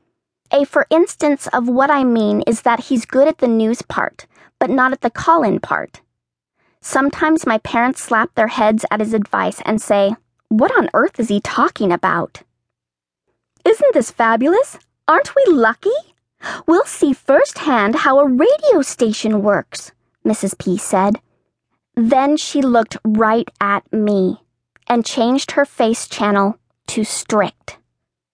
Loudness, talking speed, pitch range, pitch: -16 LUFS, 150 wpm, 210-280 Hz, 235 Hz